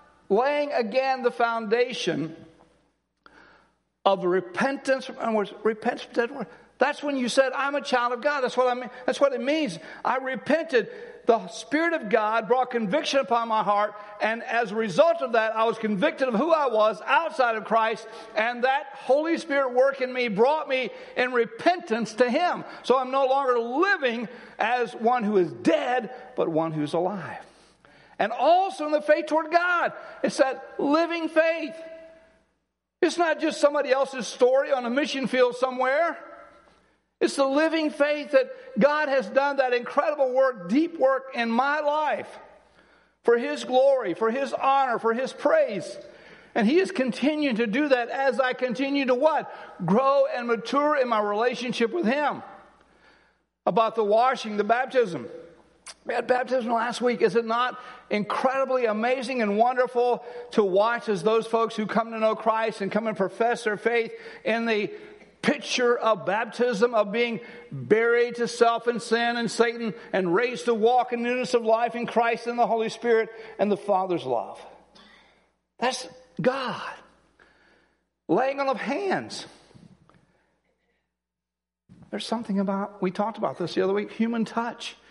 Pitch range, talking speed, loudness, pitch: 225-275 Hz, 160 wpm, -25 LUFS, 245 Hz